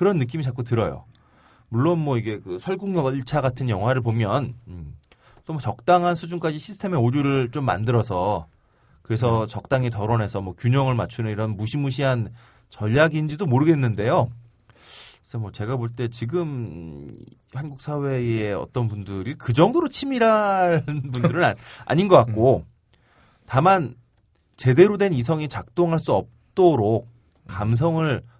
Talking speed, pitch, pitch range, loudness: 295 characters per minute, 125 Hz, 110-155 Hz, -22 LUFS